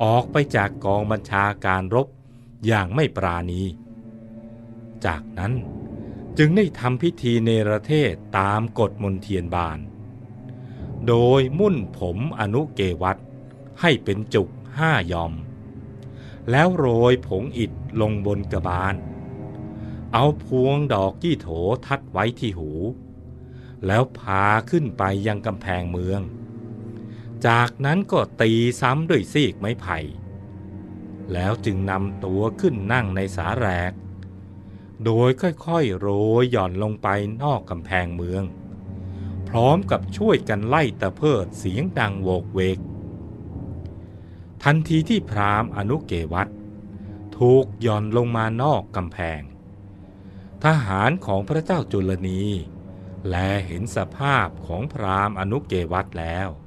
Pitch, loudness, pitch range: 105 Hz, -22 LUFS, 95-125 Hz